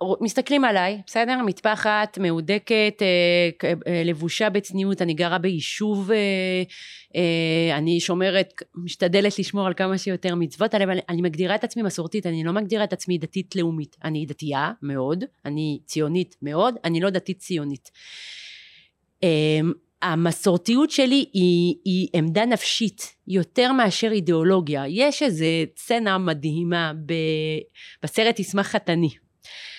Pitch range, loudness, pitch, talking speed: 165-210 Hz, -22 LUFS, 185 Hz, 120 wpm